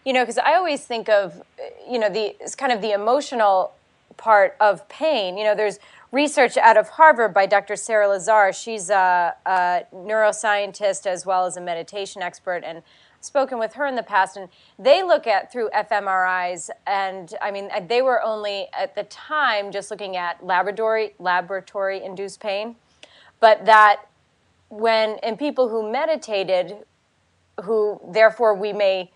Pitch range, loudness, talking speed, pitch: 195-235 Hz, -20 LUFS, 165 wpm, 210 Hz